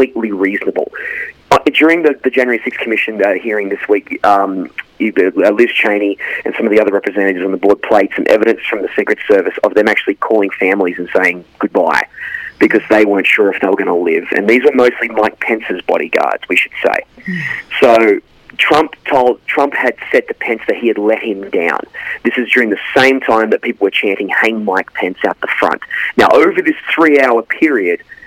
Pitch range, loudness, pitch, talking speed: 100-165 Hz, -13 LUFS, 120 Hz, 205 wpm